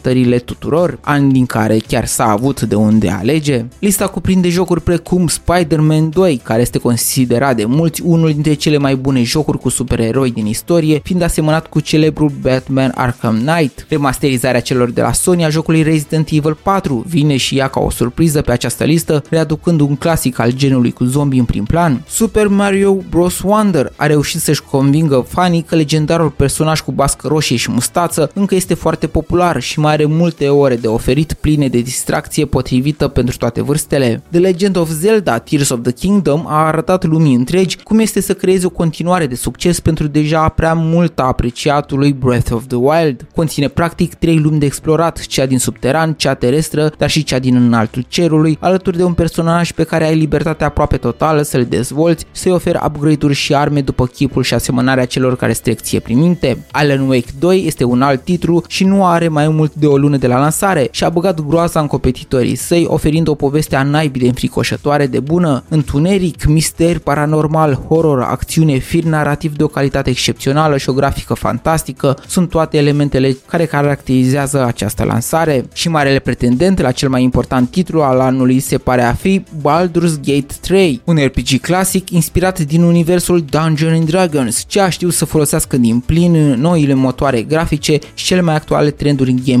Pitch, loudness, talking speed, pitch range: 150 Hz, -13 LUFS, 180 wpm, 130-165 Hz